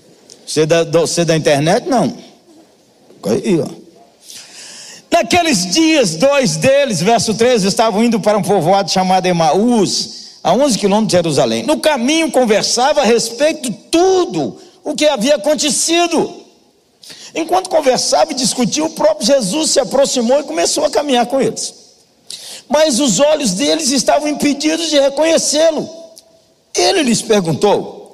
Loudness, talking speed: -13 LUFS, 130 wpm